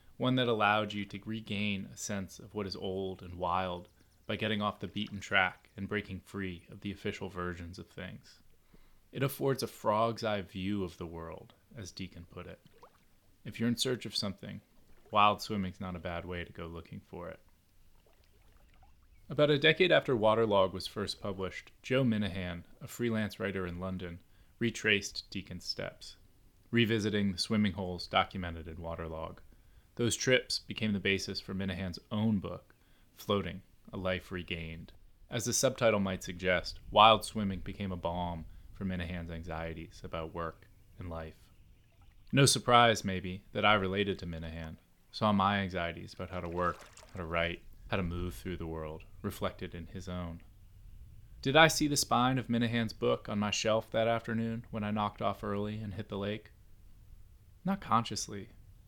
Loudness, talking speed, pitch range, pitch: -33 LUFS, 170 wpm, 90-110 Hz, 95 Hz